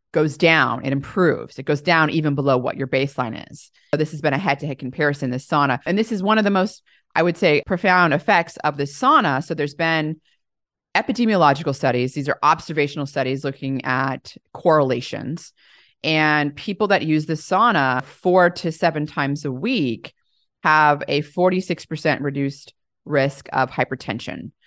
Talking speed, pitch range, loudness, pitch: 165 wpm, 135-165 Hz, -20 LUFS, 150 Hz